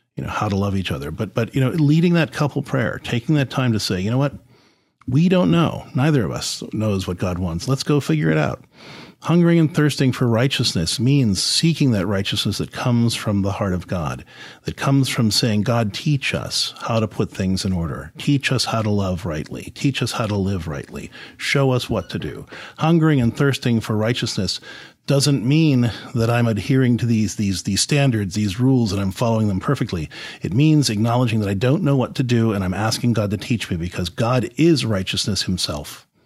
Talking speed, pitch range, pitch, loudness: 210 wpm, 100-135 Hz, 115 Hz, -20 LUFS